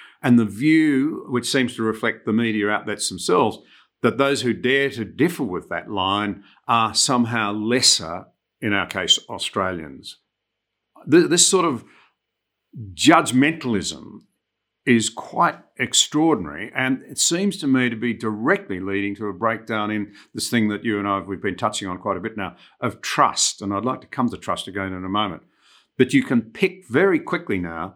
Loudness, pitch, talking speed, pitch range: -21 LUFS, 115 Hz, 175 wpm, 105-130 Hz